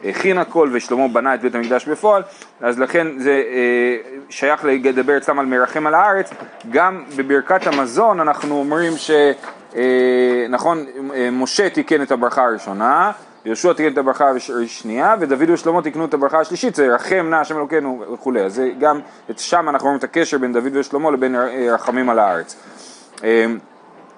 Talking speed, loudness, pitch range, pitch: 160 wpm, -17 LUFS, 125-155 Hz, 140 Hz